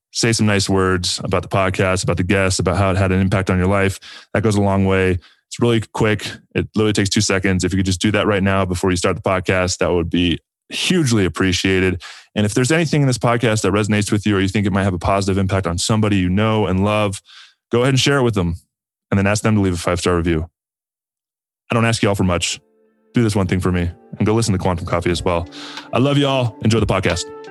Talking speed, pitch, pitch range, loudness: 265 wpm, 100 Hz, 95-110 Hz, -18 LUFS